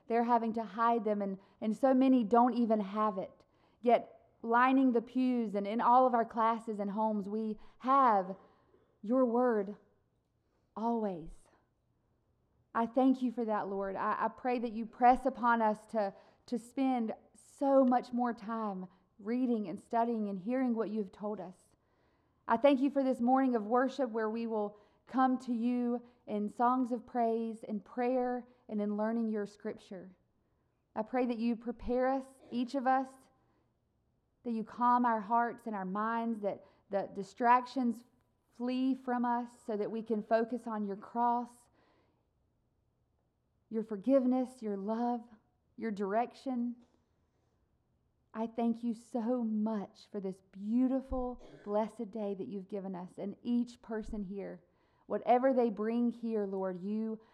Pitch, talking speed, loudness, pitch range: 230 Hz, 155 wpm, -33 LUFS, 215-245 Hz